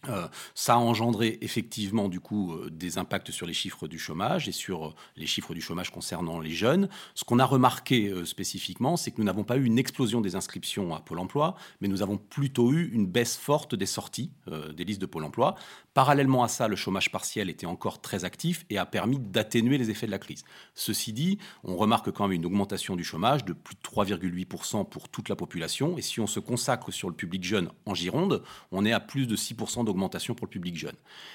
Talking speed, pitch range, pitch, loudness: 230 wpm, 95-125 Hz, 110 Hz, -29 LUFS